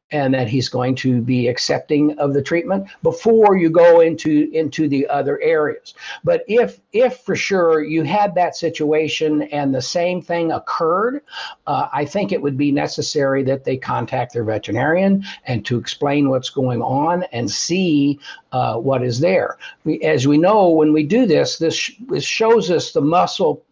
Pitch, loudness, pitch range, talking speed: 155 Hz, -17 LUFS, 140-185 Hz, 175 wpm